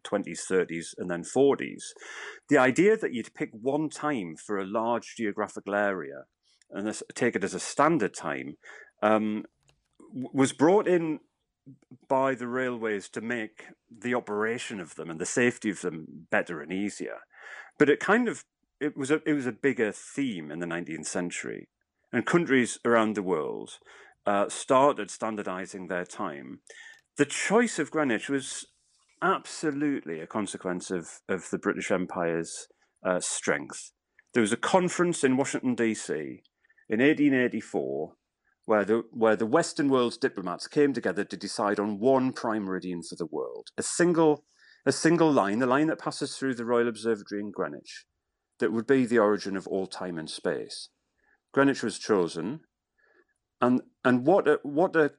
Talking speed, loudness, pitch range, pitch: 160 wpm, -28 LUFS, 105-150 Hz, 125 Hz